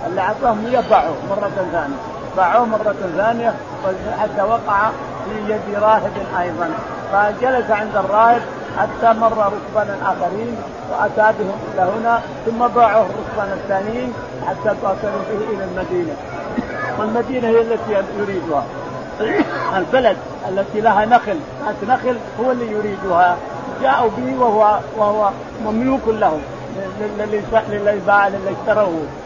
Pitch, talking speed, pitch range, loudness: 210 Hz, 115 wpm, 200-225 Hz, -18 LUFS